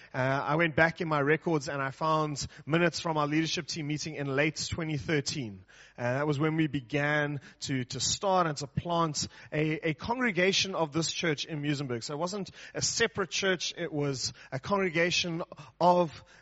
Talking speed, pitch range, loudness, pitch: 185 wpm, 145-170 Hz, -30 LUFS, 155 Hz